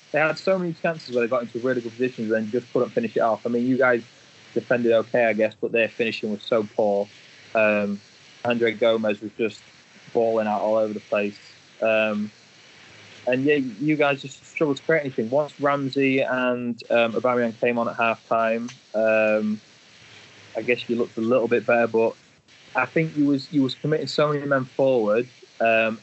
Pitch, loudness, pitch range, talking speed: 120 Hz, -23 LUFS, 110-135 Hz, 195 wpm